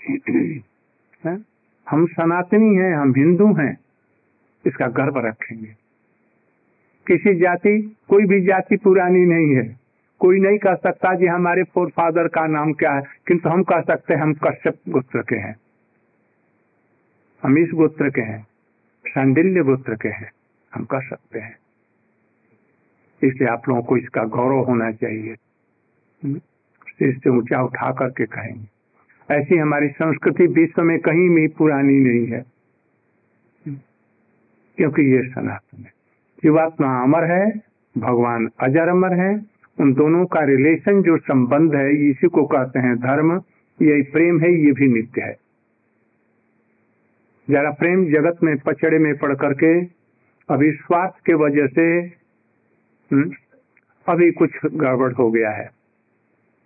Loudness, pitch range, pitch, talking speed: -18 LUFS, 135-175 Hz, 155 Hz, 130 wpm